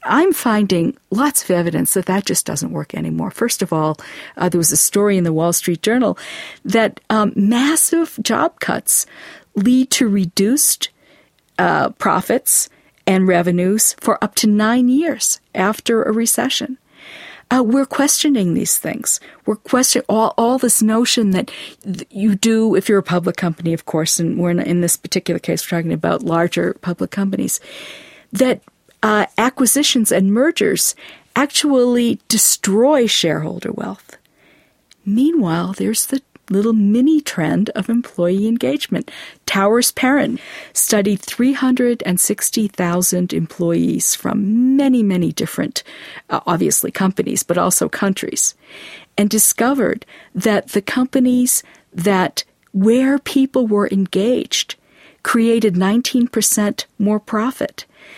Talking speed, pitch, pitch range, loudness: 130 wpm, 220 Hz, 190-255 Hz, -16 LUFS